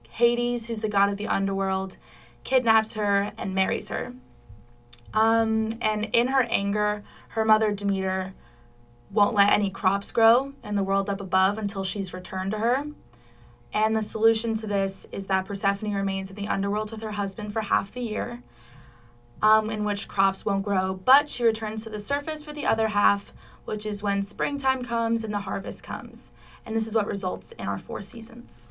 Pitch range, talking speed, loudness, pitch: 195-225 Hz, 185 wpm, -25 LUFS, 210 Hz